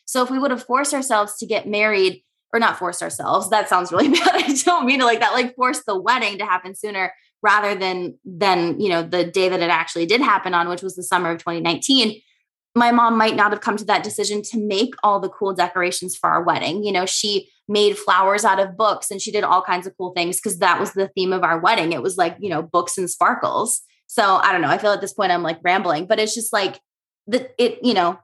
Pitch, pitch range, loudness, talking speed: 205 Hz, 180-230 Hz, -19 LUFS, 255 wpm